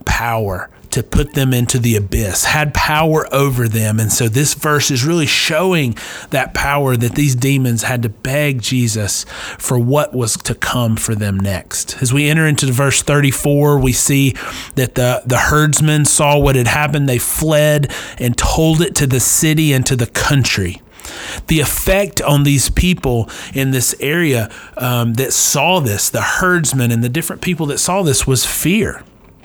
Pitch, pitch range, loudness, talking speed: 135 Hz, 120-150 Hz, -14 LUFS, 175 wpm